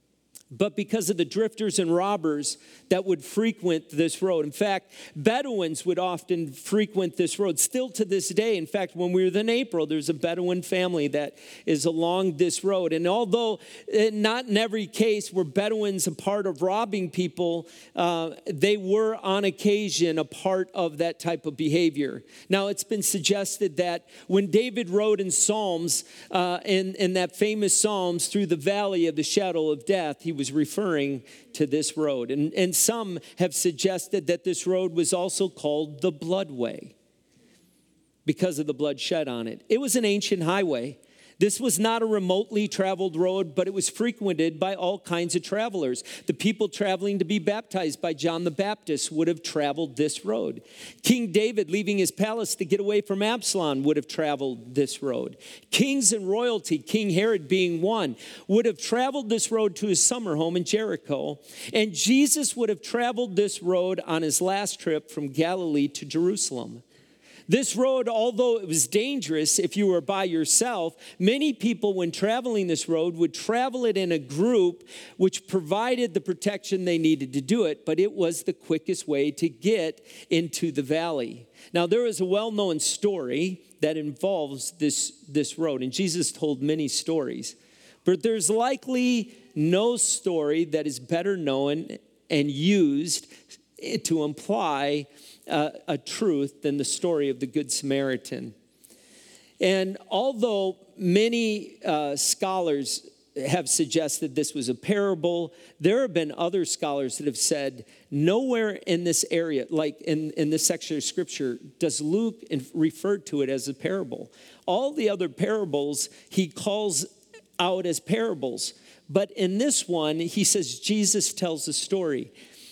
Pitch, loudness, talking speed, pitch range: 185 Hz, -26 LUFS, 165 wpm, 160-205 Hz